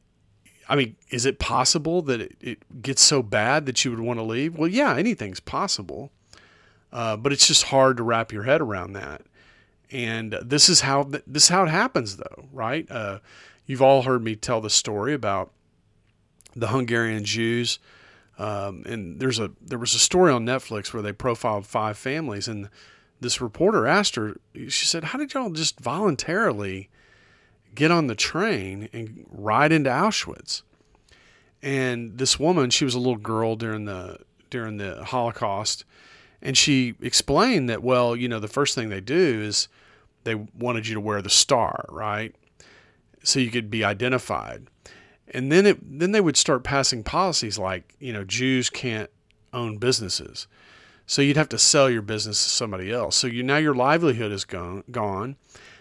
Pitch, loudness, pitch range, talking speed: 120 Hz, -22 LUFS, 105-135 Hz, 175 wpm